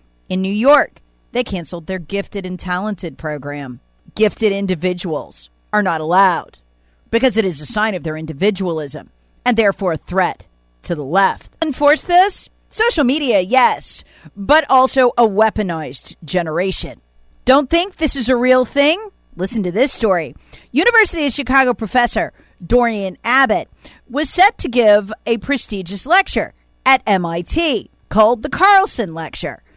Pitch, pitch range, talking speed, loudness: 210 Hz, 170-265 Hz, 140 wpm, -16 LUFS